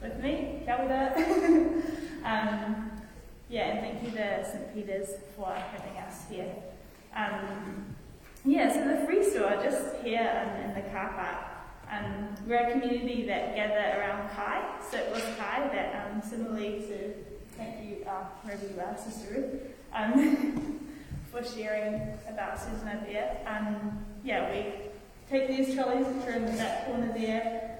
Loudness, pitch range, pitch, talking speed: -32 LUFS, 205-260 Hz, 220 Hz, 155 wpm